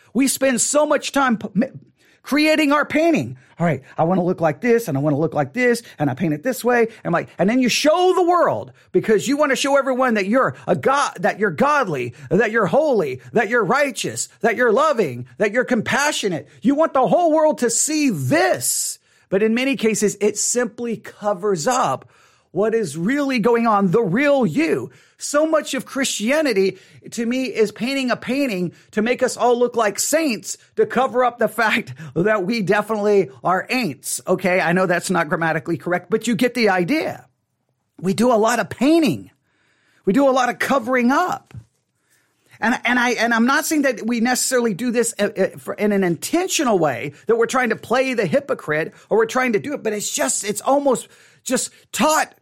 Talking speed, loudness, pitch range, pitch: 200 wpm, -19 LUFS, 190-260 Hz, 230 Hz